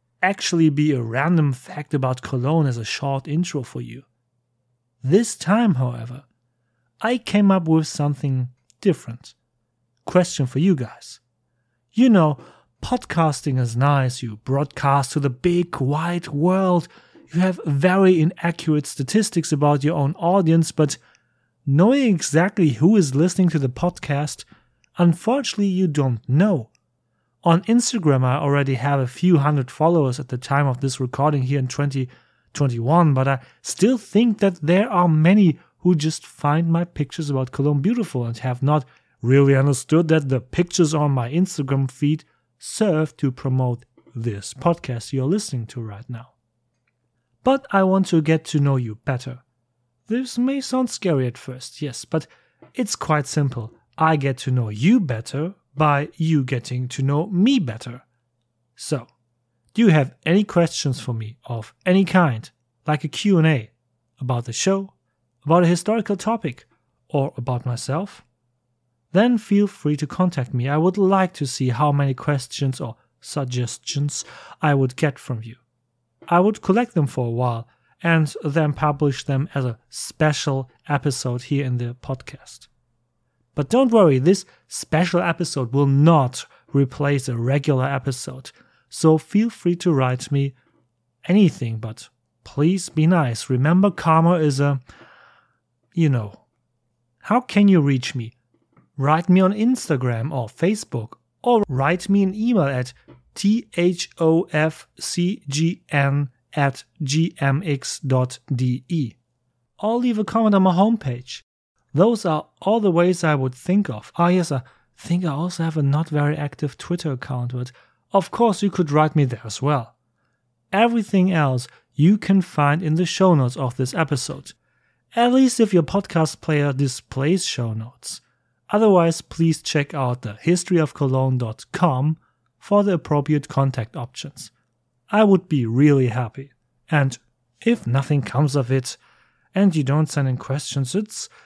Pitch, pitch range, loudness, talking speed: 145 Hz, 125-175 Hz, -20 LUFS, 150 wpm